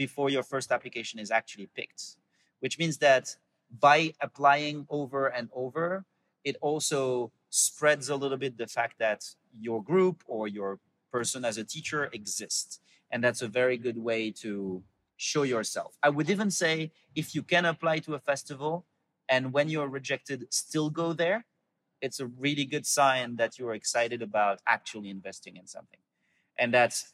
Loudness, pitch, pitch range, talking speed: -29 LUFS, 135 Hz, 115-150 Hz, 165 wpm